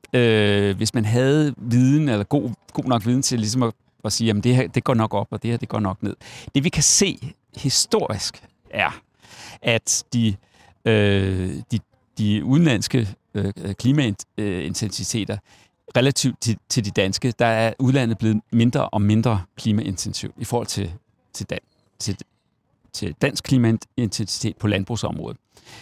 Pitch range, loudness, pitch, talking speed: 105-125 Hz, -21 LUFS, 115 Hz, 155 wpm